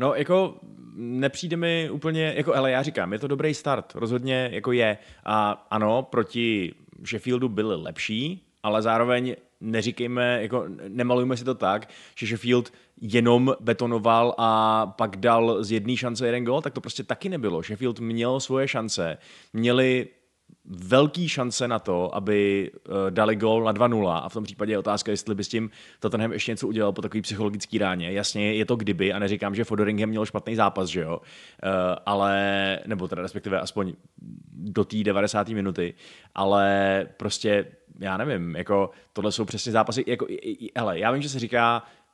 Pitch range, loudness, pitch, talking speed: 105-125 Hz, -25 LUFS, 110 Hz, 170 wpm